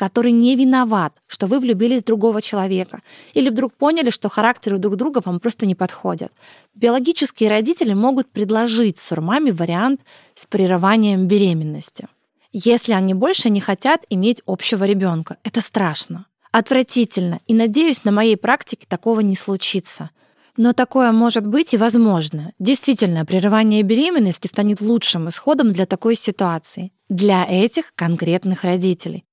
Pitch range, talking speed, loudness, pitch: 190-240 Hz, 135 wpm, -17 LUFS, 215 Hz